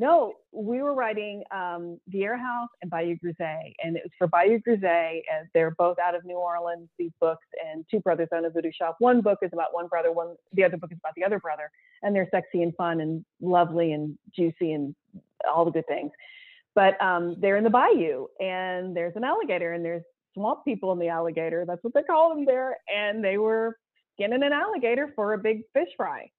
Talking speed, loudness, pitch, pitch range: 220 wpm, -26 LUFS, 180 Hz, 170-220 Hz